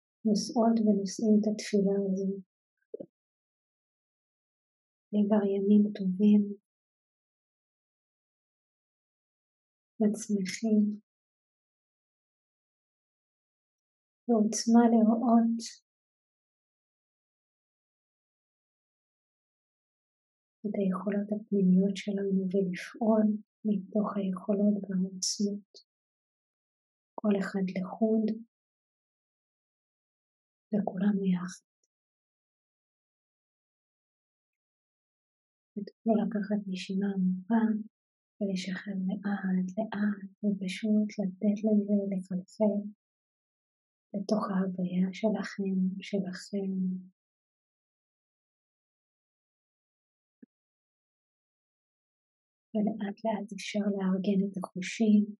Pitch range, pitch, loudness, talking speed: 195-215 Hz, 205 Hz, -30 LUFS, 50 wpm